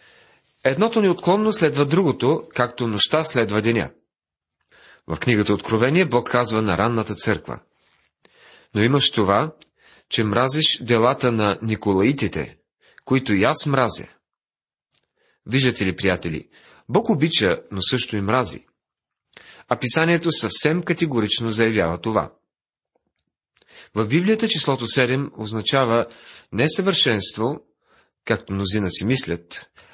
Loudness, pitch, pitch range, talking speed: -19 LUFS, 120 Hz, 105-155 Hz, 105 wpm